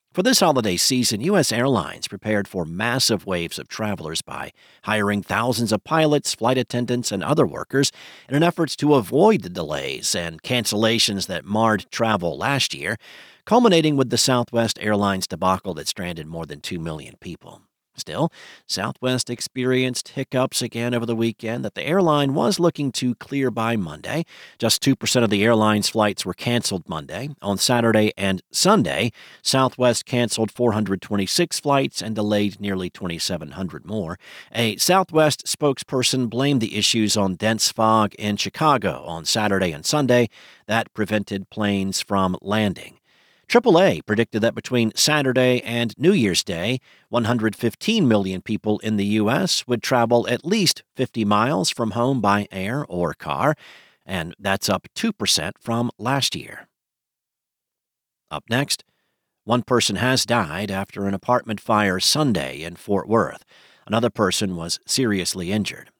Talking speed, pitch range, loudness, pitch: 145 wpm, 100-130 Hz, -21 LUFS, 115 Hz